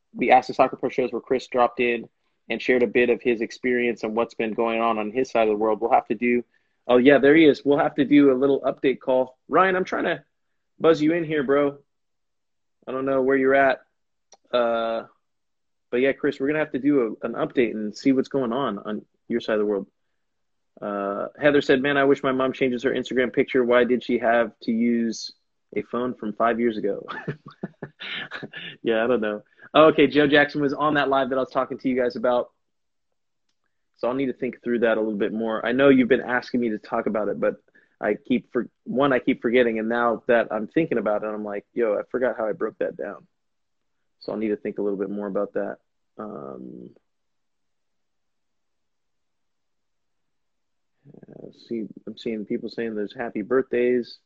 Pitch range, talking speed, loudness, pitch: 115-135 Hz, 215 wpm, -23 LUFS, 120 Hz